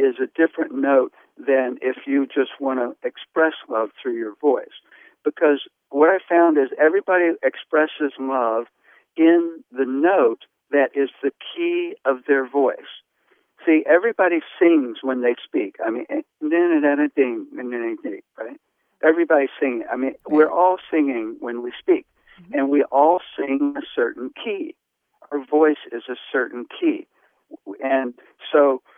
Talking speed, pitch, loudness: 140 wpm, 165 Hz, -21 LUFS